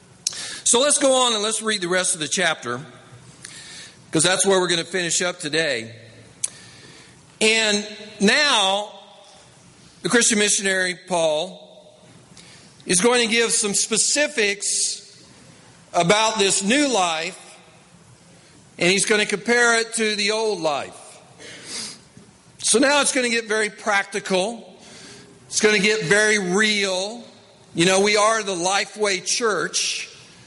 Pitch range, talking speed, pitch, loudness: 175-215 Hz, 135 wpm, 200 Hz, -19 LUFS